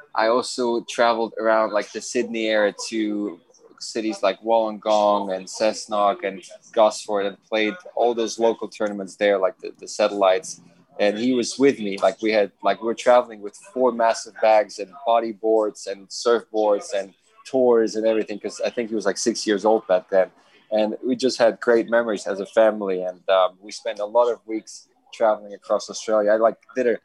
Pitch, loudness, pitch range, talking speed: 110 Hz, -22 LUFS, 105-115 Hz, 190 wpm